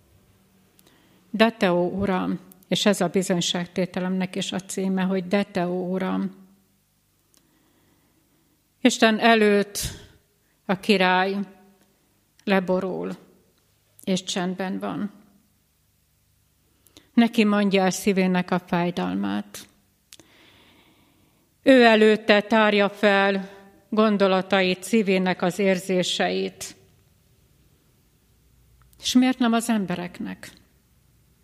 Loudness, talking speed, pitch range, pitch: -22 LUFS, 75 wpm, 180-205 Hz, 190 Hz